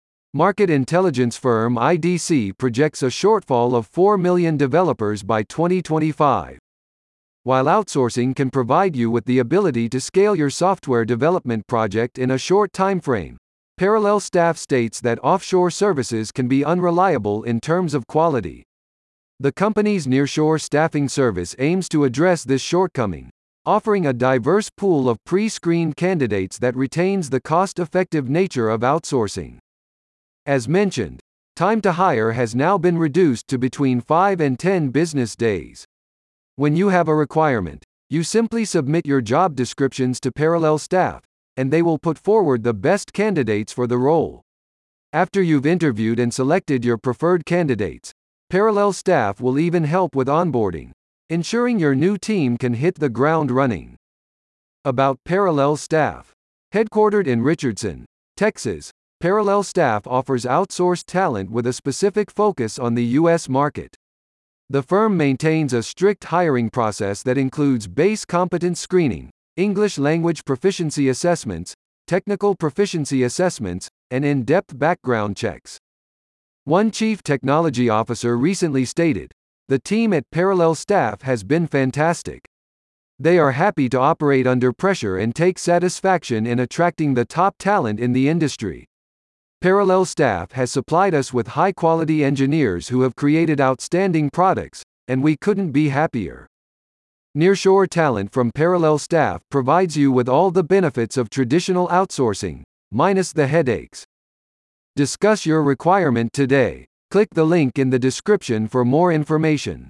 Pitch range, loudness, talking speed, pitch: 120-180 Hz, -19 LUFS, 140 wpm, 145 Hz